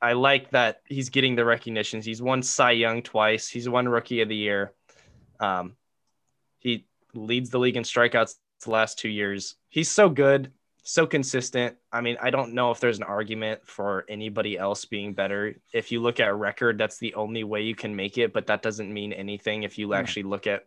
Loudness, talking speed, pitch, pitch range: -25 LUFS, 210 wpm, 115 Hz, 105-125 Hz